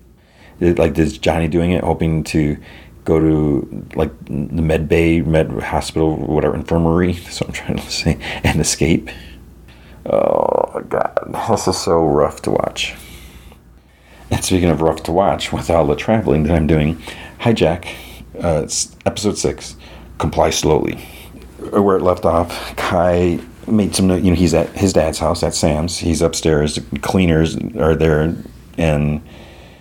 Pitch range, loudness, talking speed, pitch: 75-85 Hz, -17 LUFS, 155 wpm, 80 Hz